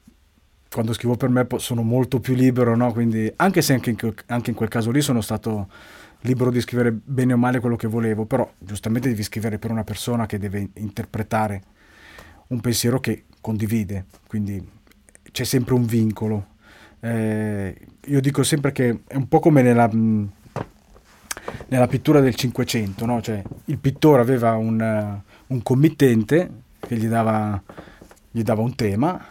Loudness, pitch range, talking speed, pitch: -21 LUFS, 110-125 Hz, 150 wpm, 115 Hz